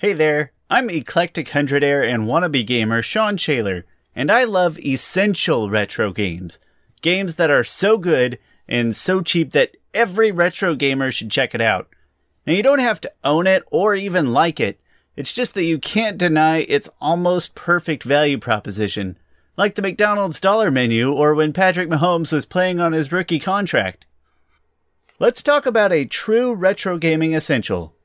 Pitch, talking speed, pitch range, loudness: 160 Hz, 165 wpm, 130-195 Hz, -18 LUFS